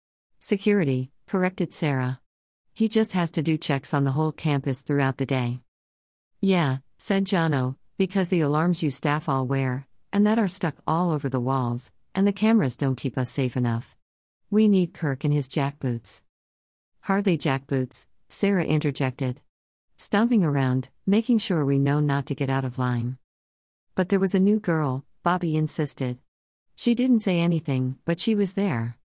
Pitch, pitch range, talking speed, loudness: 140 Hz, 130-180 Hz, 165 wpm, -25 LUFS